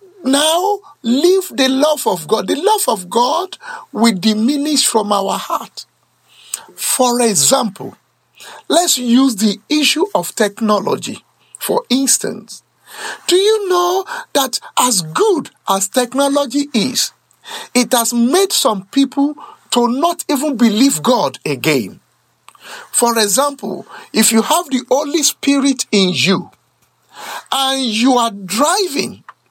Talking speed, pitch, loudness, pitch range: 120 wpm, 270 Hz, -14 LUFS, 230-305 Hz